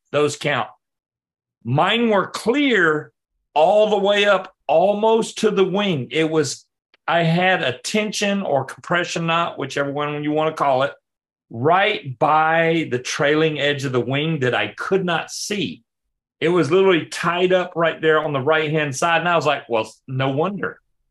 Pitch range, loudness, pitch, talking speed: 145-185 Hz, -19 LUFS, 160 Hz, 175 wpm